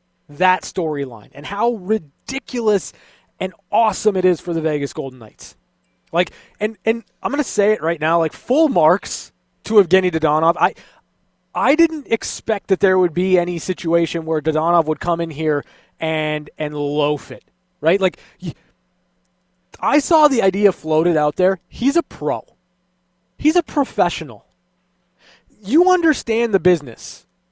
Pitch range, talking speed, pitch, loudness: 155-220 Hz, 150 wpm, 185 Hz, -18 LUFS